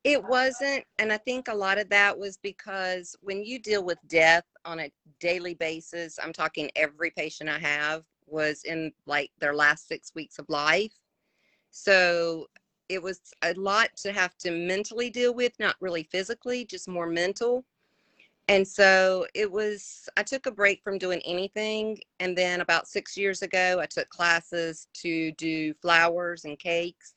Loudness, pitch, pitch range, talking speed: -26 LUFS, 180 Hz, 165-205 Hz, 170 wpm